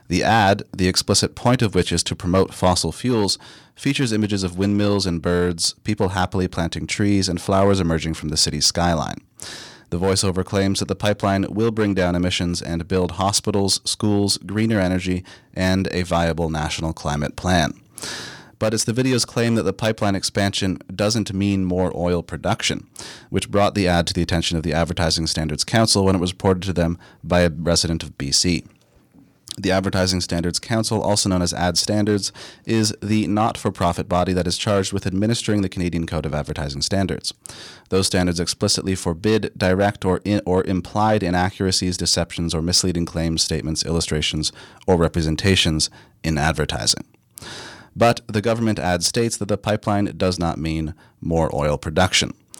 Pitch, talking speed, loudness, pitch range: 95 Hz, 165 wpm, -20 LUFS, 85-105 Hz